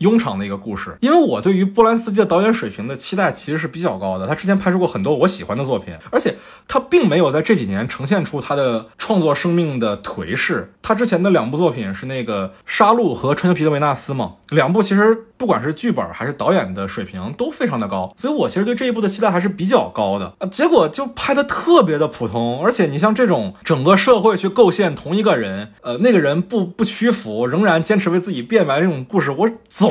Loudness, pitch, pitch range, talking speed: -17 LUFS, 180 Hz, 150-220 Hz, 360 characters per minute